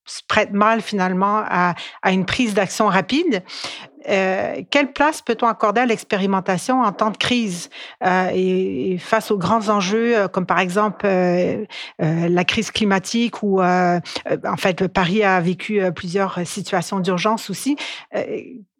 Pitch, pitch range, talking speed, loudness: 200 Hz, 185-225 Hz, 150 wpm, -19 LUFS